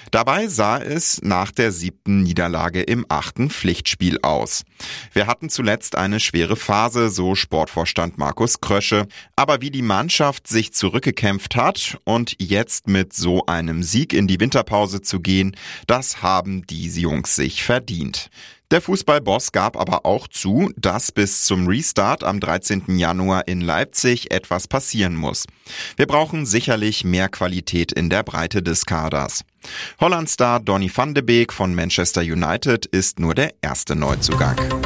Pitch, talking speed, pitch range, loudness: 95 Hz, 150 wpm, 90-115 Hz, -19 LUFS